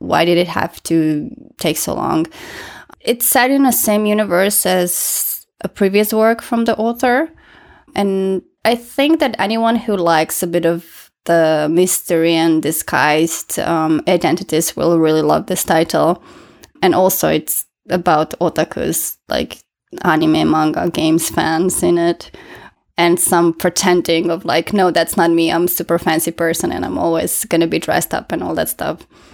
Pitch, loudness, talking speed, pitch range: 175 Hz, -15 LUFS, 165 wpm, 165-210 Hz